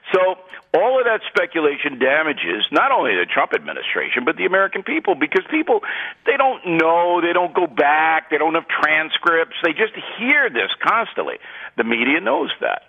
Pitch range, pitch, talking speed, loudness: 165-265 Hz, 180 Hz, 170 wpm, -18 LUFS